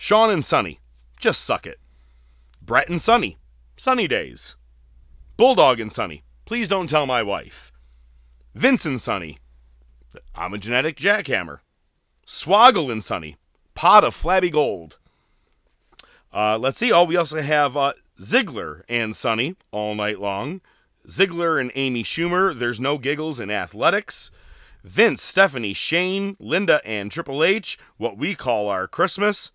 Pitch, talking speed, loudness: 120 Hz, 140 wpm, -20 LUFS